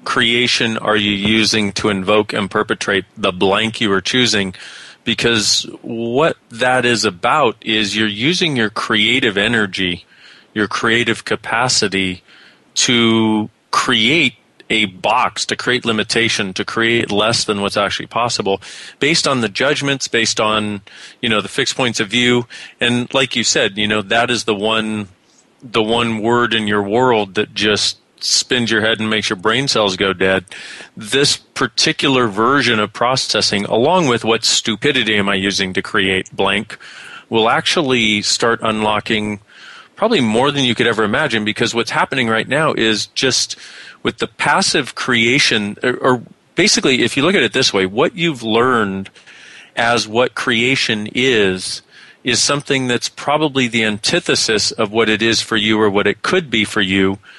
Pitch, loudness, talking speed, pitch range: 110 Hz, -15 LUFS, 160 wpm, 105-120 Hz